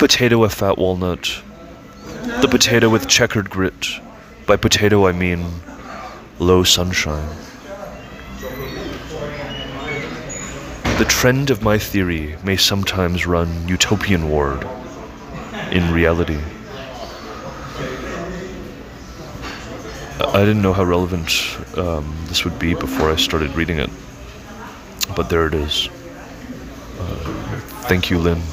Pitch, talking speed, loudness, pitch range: 90 Hz, 105 wpm, -18 LUFS, 85-100 Hz